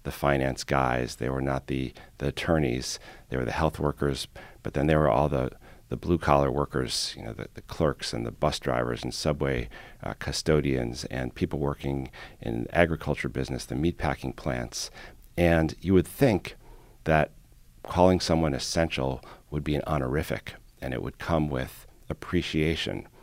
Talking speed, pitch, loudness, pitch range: 165 wpm, 70 Hz, -28 LUFS, 65-80 Hz